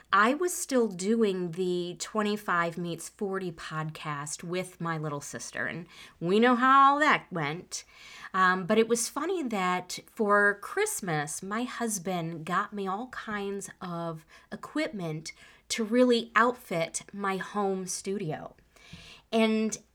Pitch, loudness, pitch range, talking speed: 195 Hz, -29 LUFS, 170-225 Hz, 130 wpm